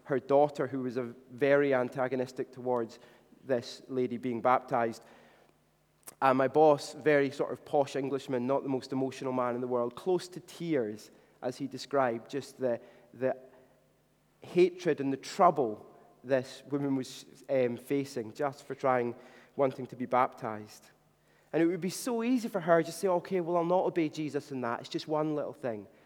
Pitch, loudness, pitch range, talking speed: 135 Hz, -31 LUFS, 125-150 Hz, 180 wpm